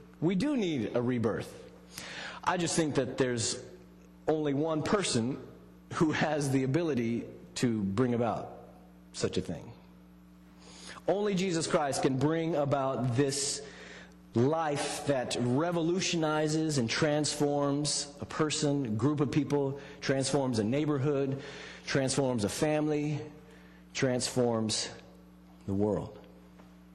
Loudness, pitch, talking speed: -31 LUFS, 135 Hz, 110 wpm